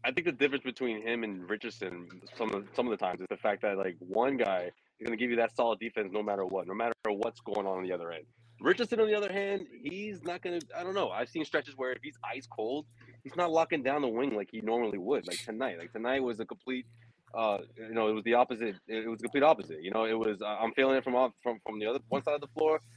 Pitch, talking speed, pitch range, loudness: 115 Hz, 285 wpm, 110-140 Hz, -33 LUFS